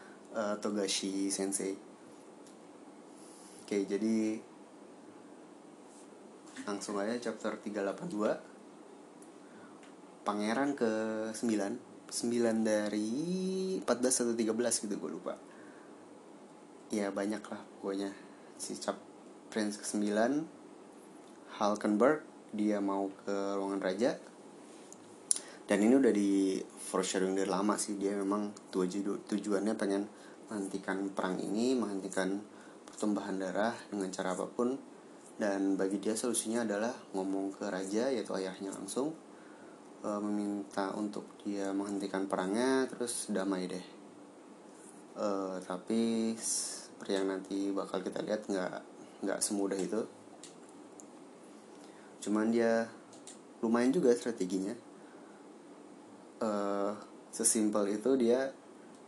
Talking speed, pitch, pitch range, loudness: 100 wpm, 100 Hz, 95-110 Hz, -34 LUFS